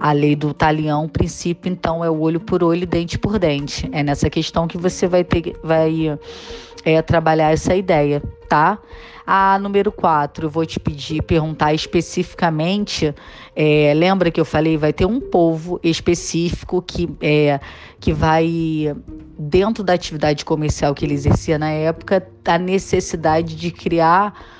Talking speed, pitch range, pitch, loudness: 160 wpm, 150-175 Hz, 160 Hz, -18 LUFS